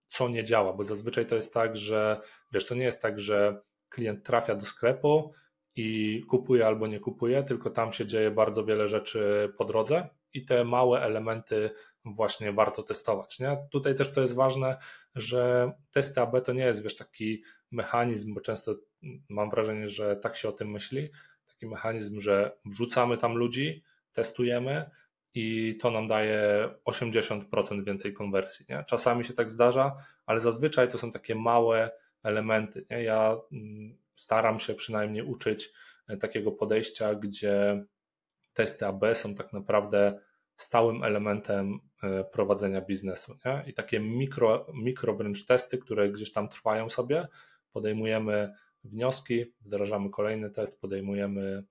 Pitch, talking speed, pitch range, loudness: 110 Hz, 145 wpm, 105-125 Hz, -29 LUFS